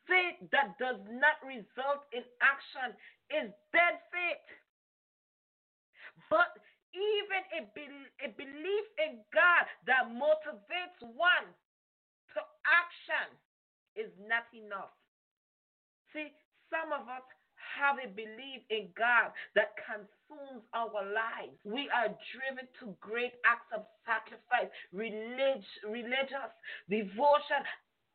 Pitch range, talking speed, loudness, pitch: 225-305 Hz, 105 wpm, -33 LUFS, 265 Hz